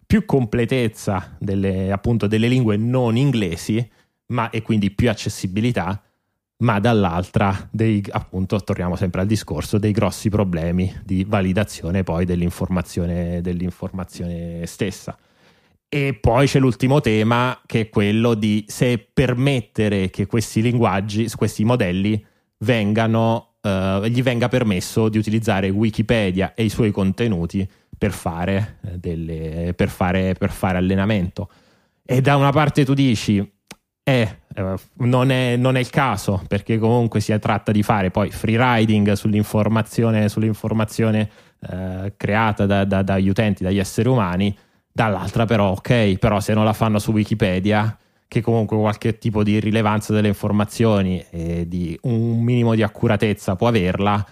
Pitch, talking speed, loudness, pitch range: 105 Hz, 135 wpm, -20 LUFS, 95-115 Hz